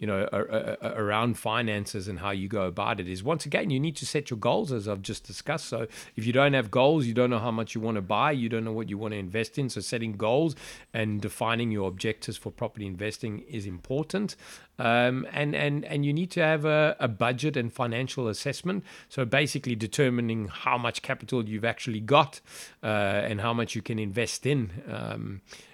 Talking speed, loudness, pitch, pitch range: 210 wpm, -28 LUFS, 115 Hz, 110-135 Hz